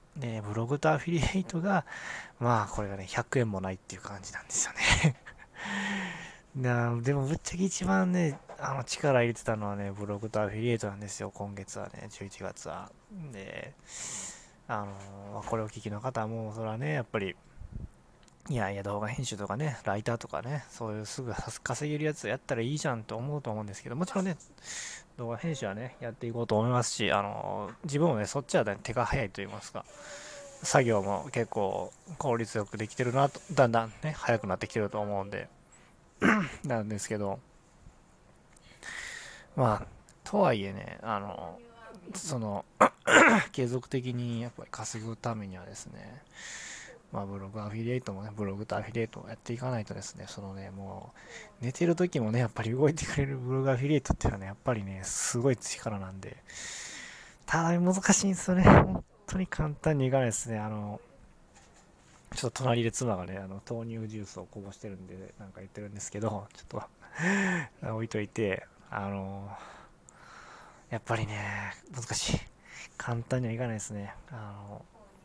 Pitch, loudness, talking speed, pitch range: 115 Hz, -31 LUFS, 350 characters per minute, 105-140 Hz